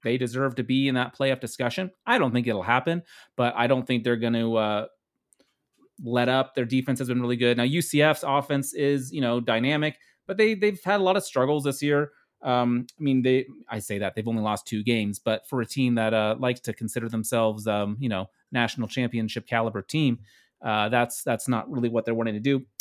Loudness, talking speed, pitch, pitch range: -25 LUFS, 225 wpm, 125 Hz, 115-135 Hz